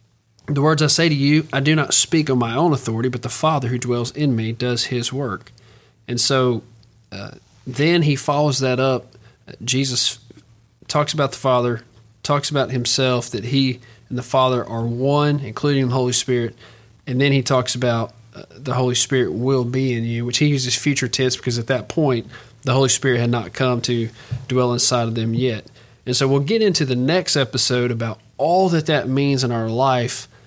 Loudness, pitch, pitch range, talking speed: -19 LUFS, 125 Hz, 120-140 Hz, 200 wpm